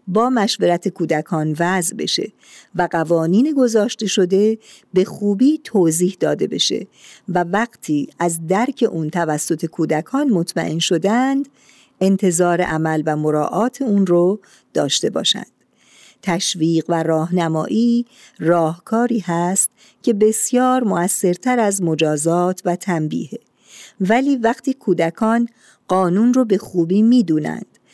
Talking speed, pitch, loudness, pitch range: 110 wpm, 185 Hz, -18 LUFS, 170-230 Hz